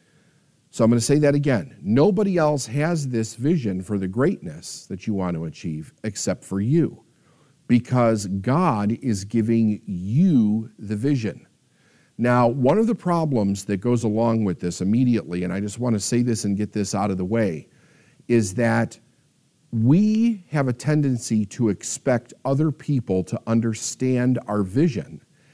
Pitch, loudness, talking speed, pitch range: 120 Hz, -22 LUFS, 160 wpm, 105-145 Hz